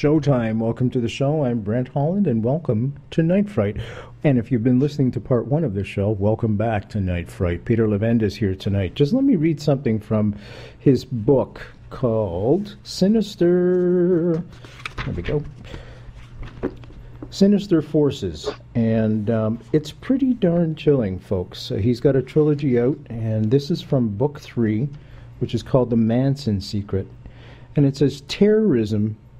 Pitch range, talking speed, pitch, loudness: 110-150 Hz, 160 wpm, 125 Hz, -21 LUFS